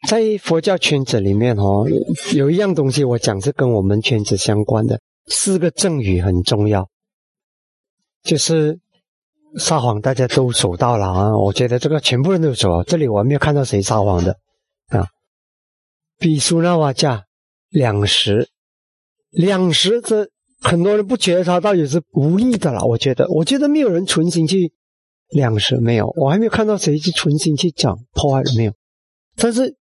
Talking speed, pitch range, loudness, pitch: 245 characters per minute, 110-180 Hz, -16 LUFS, 145 Hz